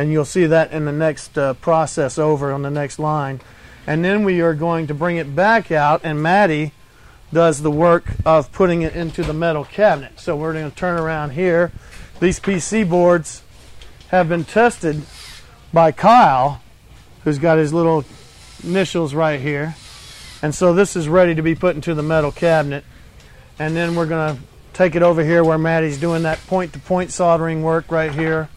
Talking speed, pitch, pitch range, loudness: 190 wpm, 160 Hz, 150-175 Hz, -17 LUFS